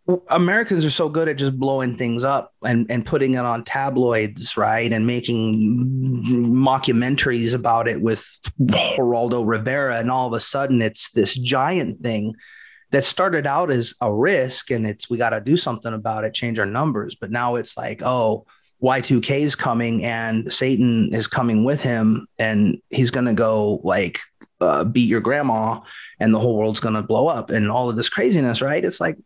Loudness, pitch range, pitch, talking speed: -20 LUFS, 115-130 Hz, 120 Hz, 185 wpm